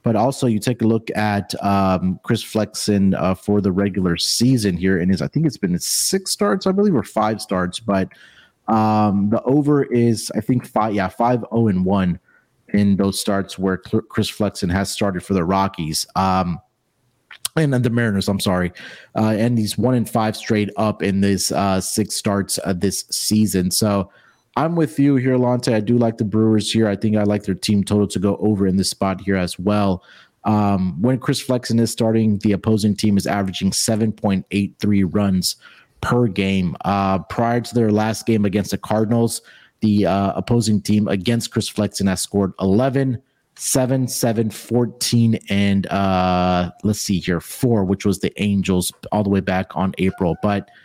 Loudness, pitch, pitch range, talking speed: -19 LUFS, 105 Hz, 95-115 Hz, 190 wpm